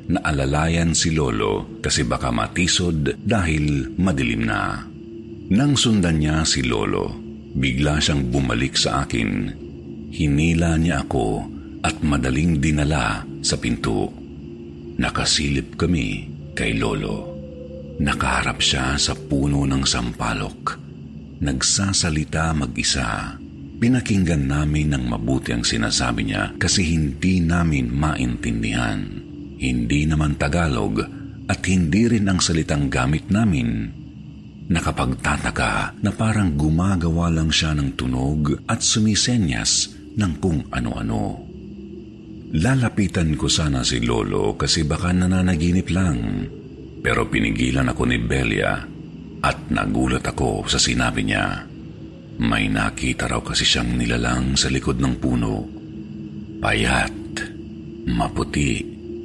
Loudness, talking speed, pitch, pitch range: -21 LUFS, 105 wpm, 75 Hz, 70-90 Hz